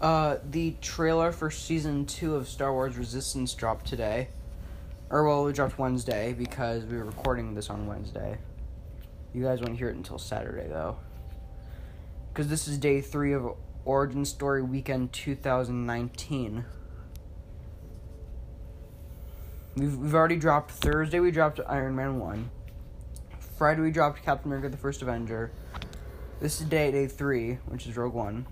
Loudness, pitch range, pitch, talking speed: -29 LUFS, 95-140 Hz, 125 Hz, 145 wpm